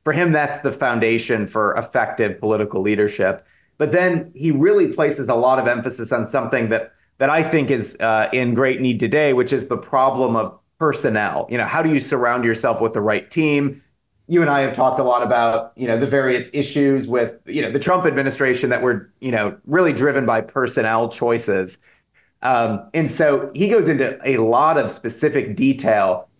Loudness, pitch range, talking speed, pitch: -18 LUFS, 115-145 Hz, 195 wpm, 130 Hz